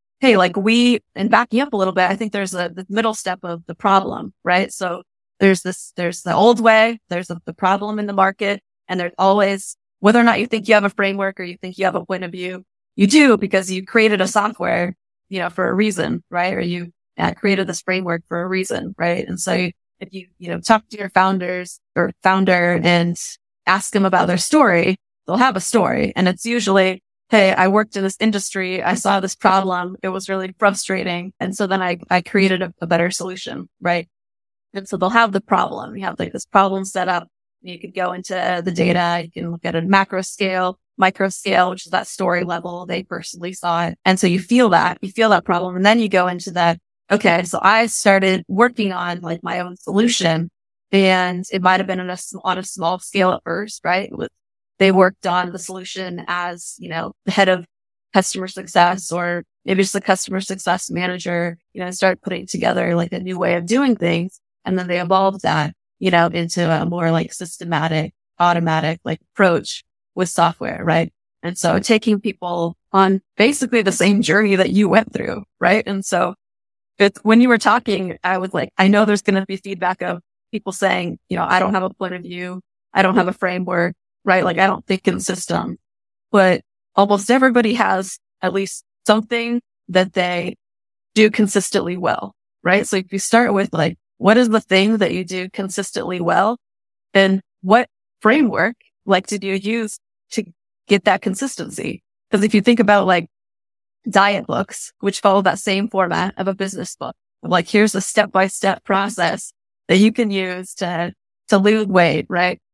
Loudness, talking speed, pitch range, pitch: -18 LUFS, 205 wpm, 180-205 Hz, 190 Hz